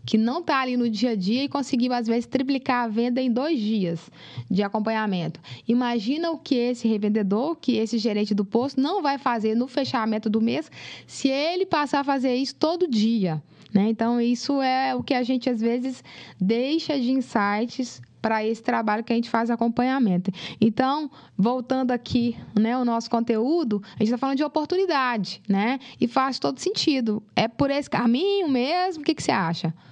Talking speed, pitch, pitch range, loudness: 190 wpm, 240 Hz, 220-270 Hz, -24 LUFS